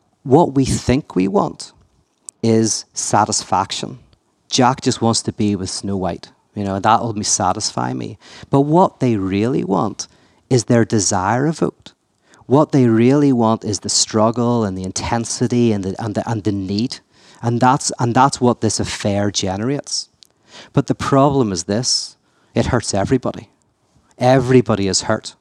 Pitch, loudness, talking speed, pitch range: 115 Hz, -17 LUFS, 155 wpm, 100-125 Hz